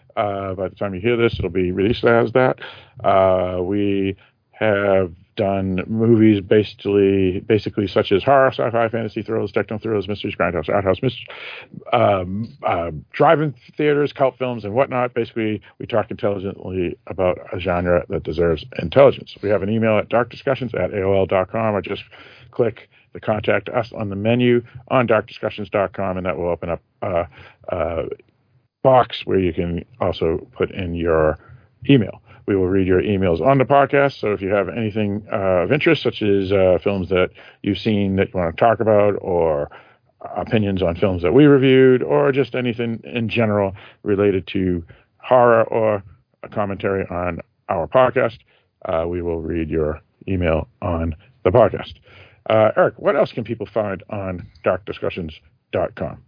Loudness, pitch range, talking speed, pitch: -19 LUFS, 95-115 Hz, 165 wpm, 105 Hz